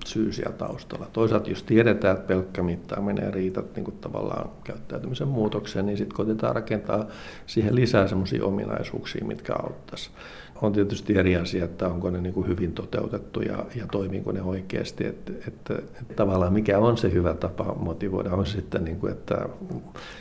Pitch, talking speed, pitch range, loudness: 100 Hz, 155 wpm, 95-110 Hz, -27 LUFS